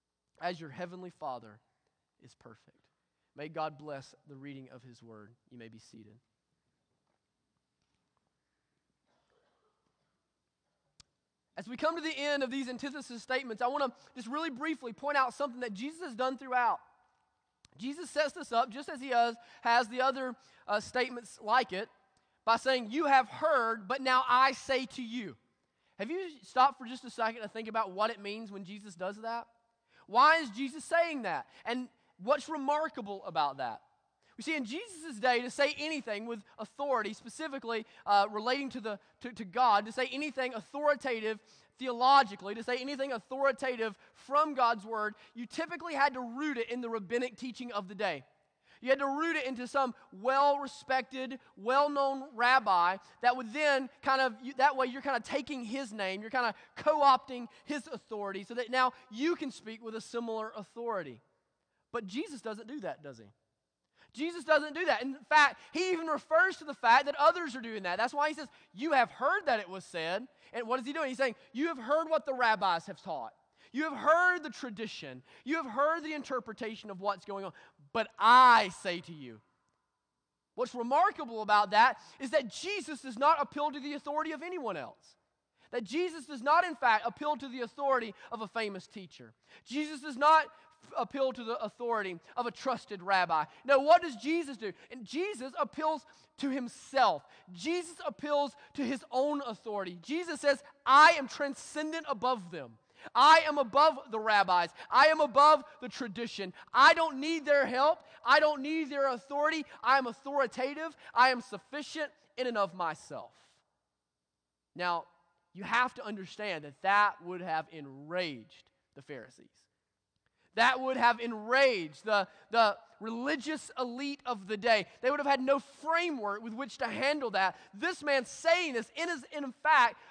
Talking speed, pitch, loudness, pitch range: 180 wpm, 255 Hz, -31 LUFS, 215-285 Hz